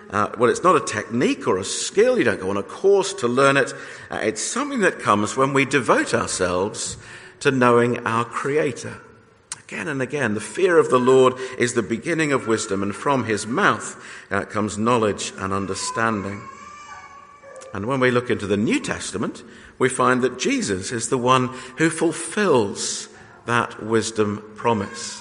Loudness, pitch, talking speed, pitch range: -21 LUFS, 130 Hz, 175 wpm, 115-165 Hz